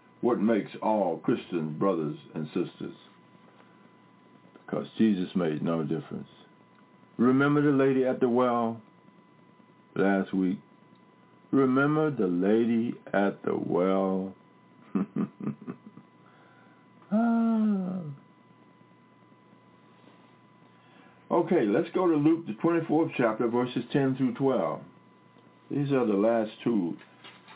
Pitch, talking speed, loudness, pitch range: 130 Hz, 95 wpm, -27 LUFS, 100-150 Hz